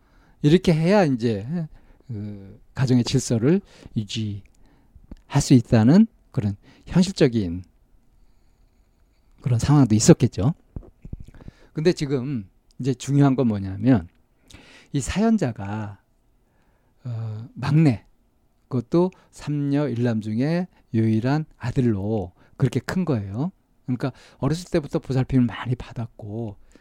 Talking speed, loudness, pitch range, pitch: 220 characters per minute, -22 LUFS, 110-145 Hz, 125 Hz